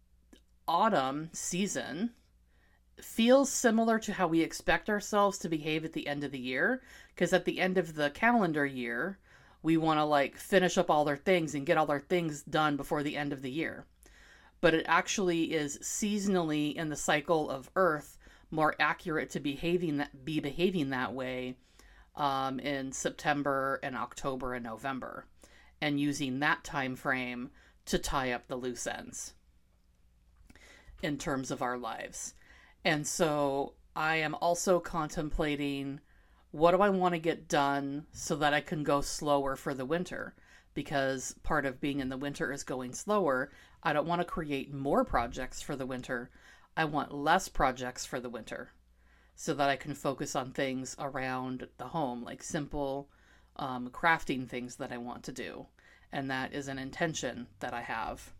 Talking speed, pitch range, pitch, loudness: 170 wpm, 135-170 Hz, 145 Hz, -32 LUFS